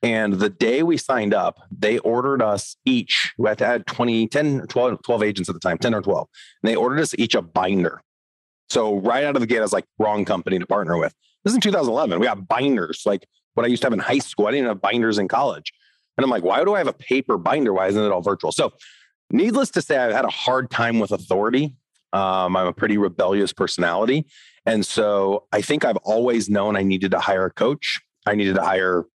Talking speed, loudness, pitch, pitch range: 245 wpm, -21 LUFS, 105 Hz, 95-130 Hz